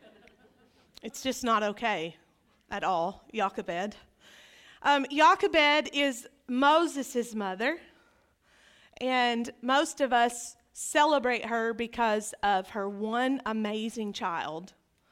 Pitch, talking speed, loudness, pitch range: 240 Hz, 95 wpm, -28 LUFS, 215-275 Hz